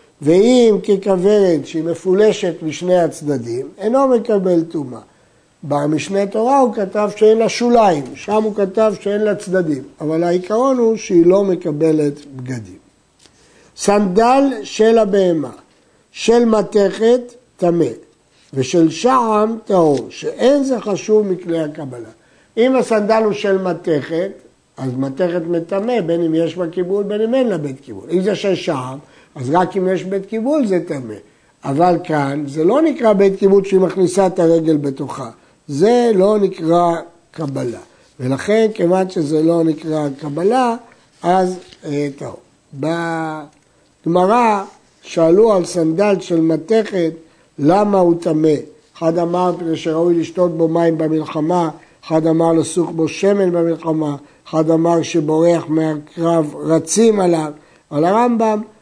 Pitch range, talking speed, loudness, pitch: 160-205 Hz, 135 wpm, -16 LUFS, 175 Hz